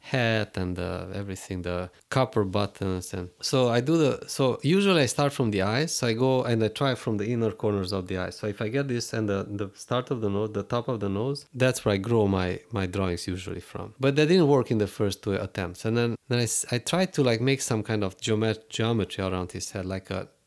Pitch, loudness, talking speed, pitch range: 110 Hz, -27 LUFS, 250 wpm, 95-130 Hz